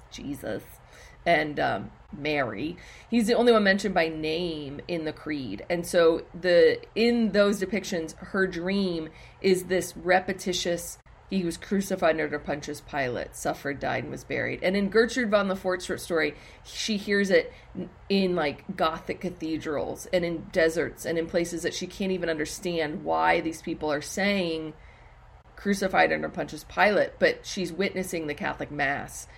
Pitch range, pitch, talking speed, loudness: 165-195 Hz, 180 Hz, 155 wpm, -27 LUFS